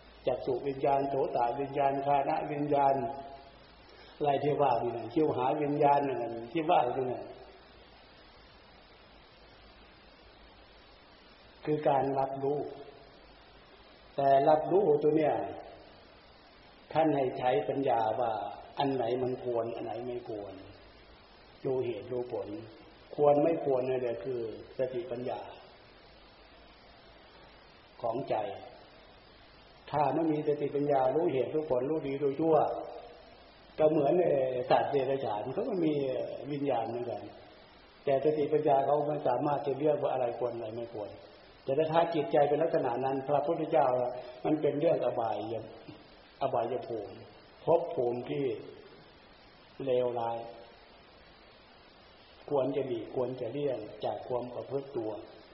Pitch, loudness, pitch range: 135 Hz, -31 LUFS, 120-150 Hz